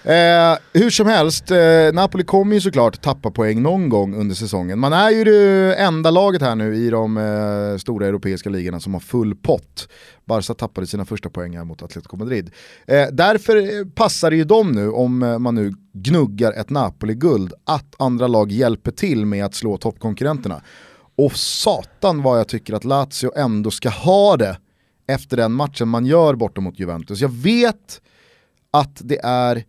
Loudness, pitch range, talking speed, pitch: -17 LUFS, 105-160 Hz, 175 wpm, 120 Hz